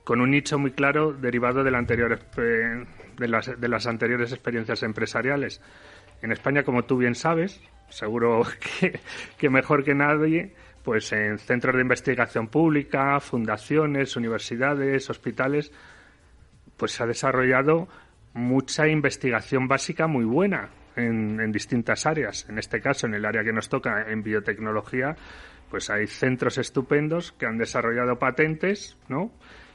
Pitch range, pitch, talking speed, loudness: 115-140 Hz, 130 Hz, 140 wpm, -25 LUFS